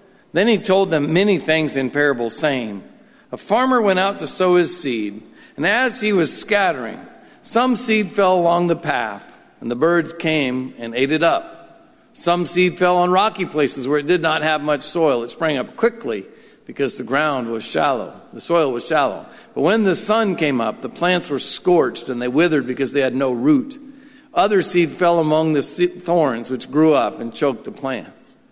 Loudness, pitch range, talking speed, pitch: -18 LUFS, 140-195 Hz, 195 wpm, 165 Hz